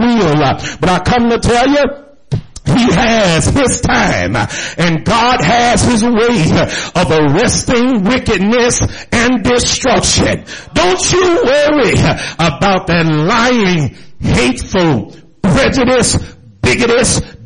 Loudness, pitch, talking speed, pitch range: -11 LUFS, 230 Hz, 100 wpm, 170-245 Hz